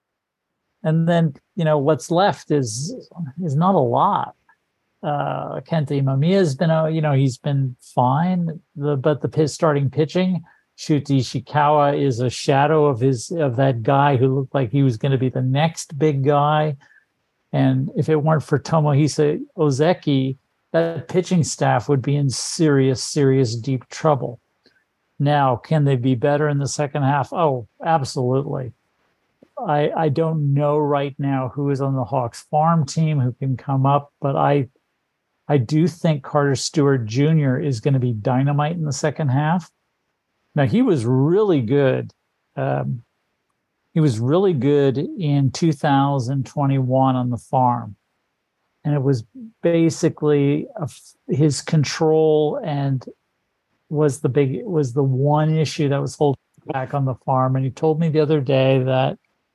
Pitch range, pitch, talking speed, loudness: 135-155 Hz, 145 Hz, 160 wpm, -20 LUFS